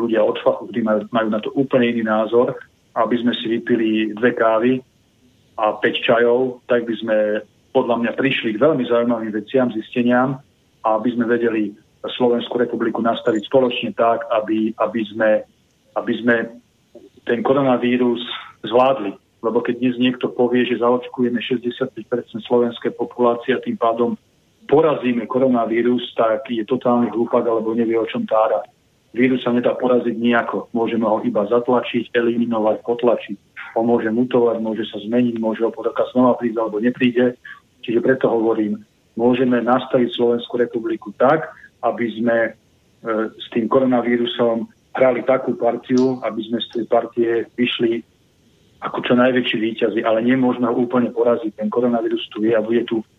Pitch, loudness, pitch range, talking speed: 120 Hz, -19 LUFS, 115-125 Hz, 150 wpm